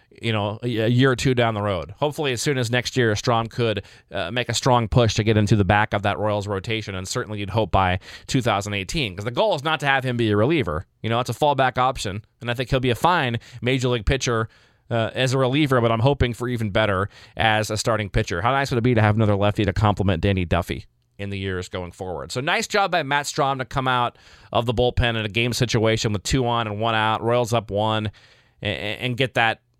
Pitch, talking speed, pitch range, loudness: 115 Hz, 250 wpm, 105-125 Hz, -22 LUFS